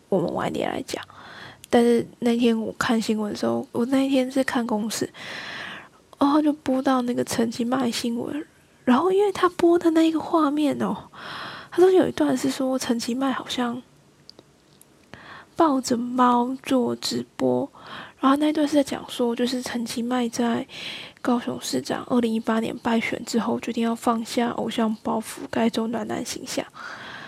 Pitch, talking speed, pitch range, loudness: 245 Hz, 245 characters per minute, 230-275 Hz, -24 LUFS